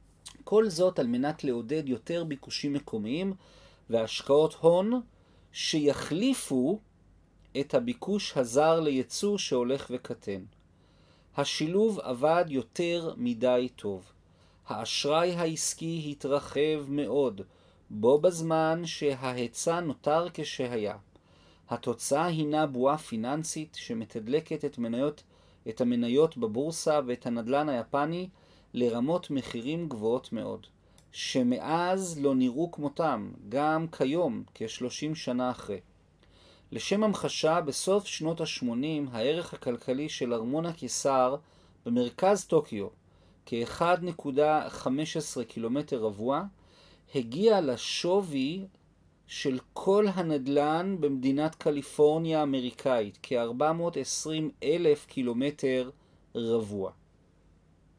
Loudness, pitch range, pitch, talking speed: -29 LUFS, 125-170 Hz, 145 Hz, 85 wpm